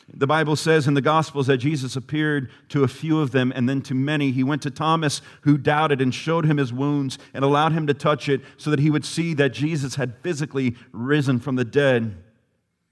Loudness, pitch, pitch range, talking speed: -22 LUFS, 140 Hz, 130-150 Hz, 225 wpm